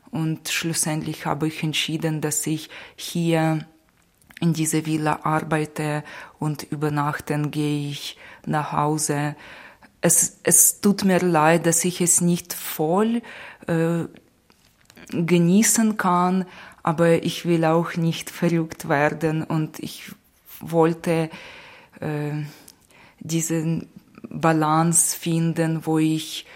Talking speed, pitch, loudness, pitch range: 105 wpm, 160 Hz, -22 LUFS, 155-170 Hz